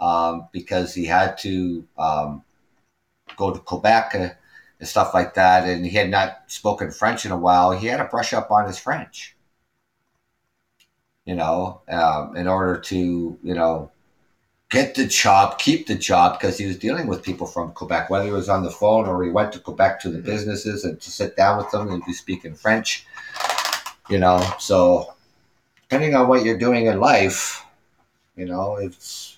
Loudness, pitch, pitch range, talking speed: -20 LUFS, 95 Hz, 90-105 Hz, 185 wpm